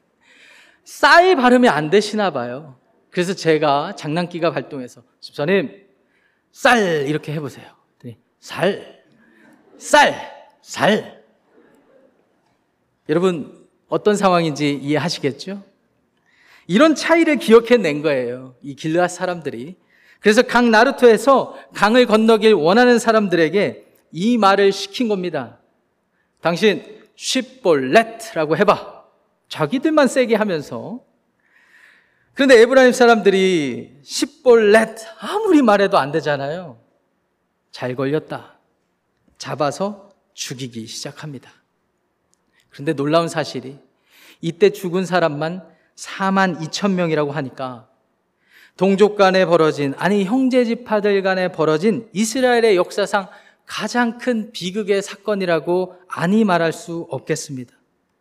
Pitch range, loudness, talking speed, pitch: 155-225 Hz, -17 LUFS, 240 characters per minute, 190 Hz